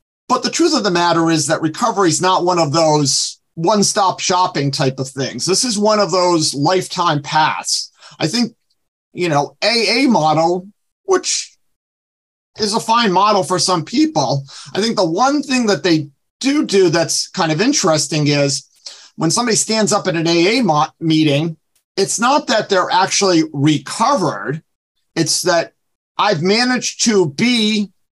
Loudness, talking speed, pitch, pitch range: -15 LUFS, 160 wpm, 180 Hz, 155-215 Hz